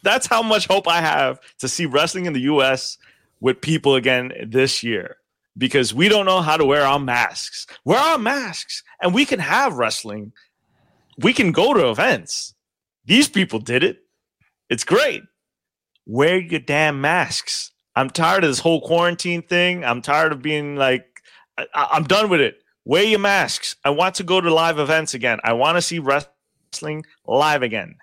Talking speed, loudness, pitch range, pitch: 180 wpm, -18 LUFS, 130-180 Hz, 155 Hz